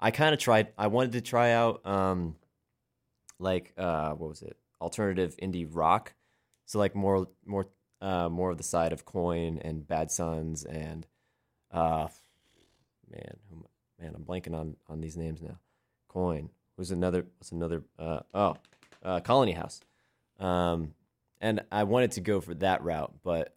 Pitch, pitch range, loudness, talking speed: 90 Hz, 80-100 Hz, -31 LUFS, 160 wpm